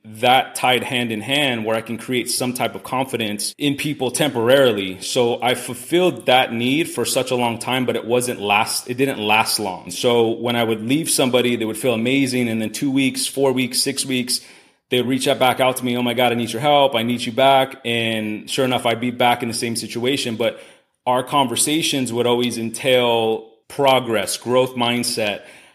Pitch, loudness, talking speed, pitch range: 125 Hz, -19 LUFS, 205 wpm, 115-130 Hz